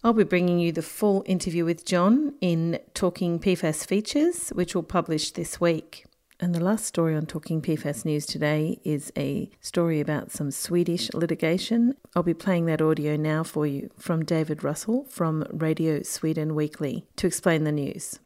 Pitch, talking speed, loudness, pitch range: 170 Hz, 175 wpm, -26 LUFS, 155-185 Hz